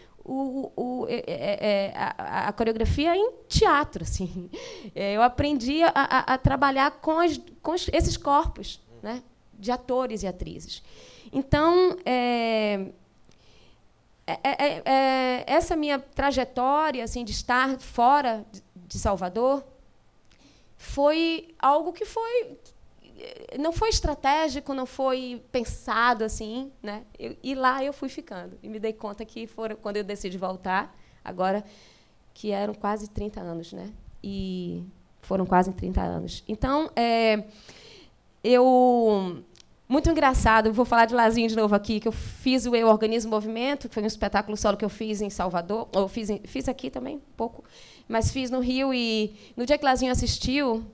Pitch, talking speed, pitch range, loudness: 245 Hz, 155 wpm, 210-275 Hz, -25 LUFS